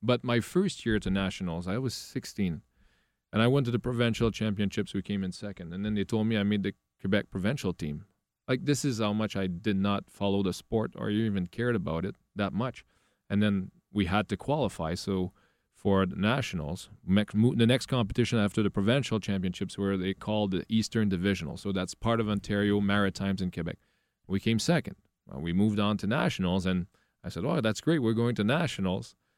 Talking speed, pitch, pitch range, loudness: 205 wpm, 100 Hz, 95-110 Hz, -30 LUFS